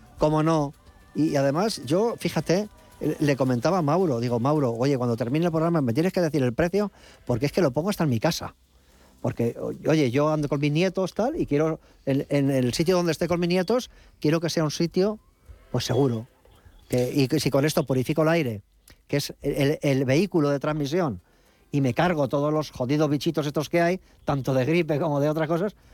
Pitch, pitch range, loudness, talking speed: 150 Hz, 135-170 Hz, -24 LUFS, 210 wpm